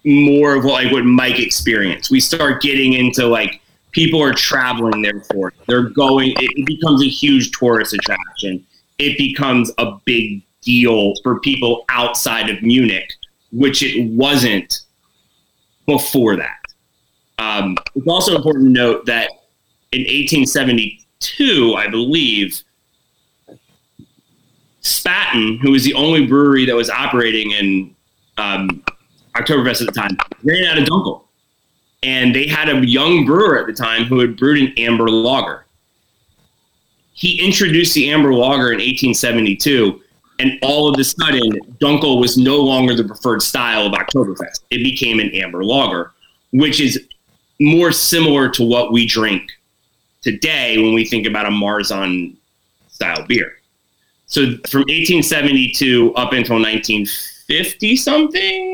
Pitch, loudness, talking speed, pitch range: 125 Hz, -14 LUFS, 135 wpm, 115-140 Hz